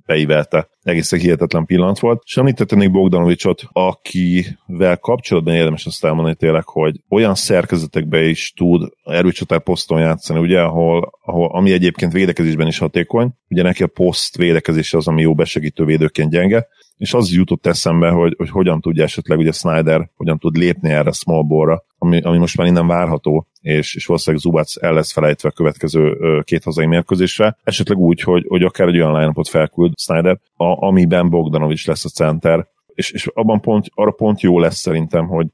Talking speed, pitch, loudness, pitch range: 170 wpm, 85 Hz, -15 LUFS, 80-90 Hz